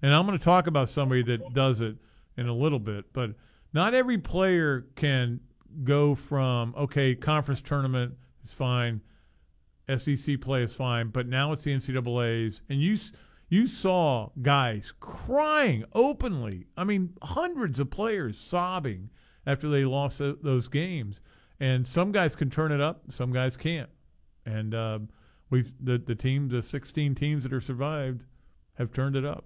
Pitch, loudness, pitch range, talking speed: 135 Hz, -28 LUFS, 120-150 Hz, 160 wpm